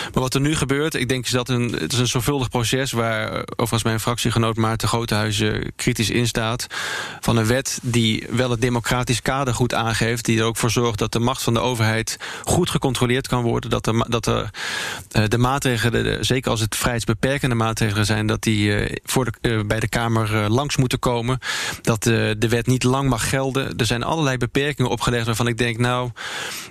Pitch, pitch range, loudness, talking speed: 120 Hz, 115-125 Hz, -21 LUFS, 200 wpm